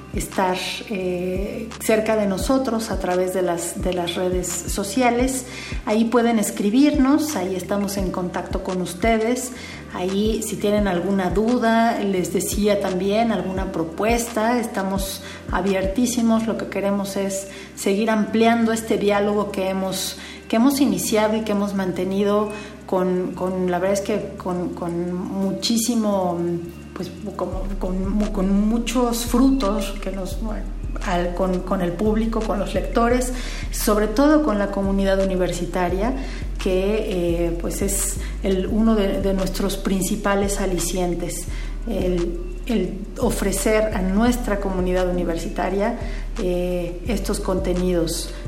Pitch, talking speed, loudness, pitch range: 195 Hz, 130 wpm, -22 LUFS, 185-220 Hz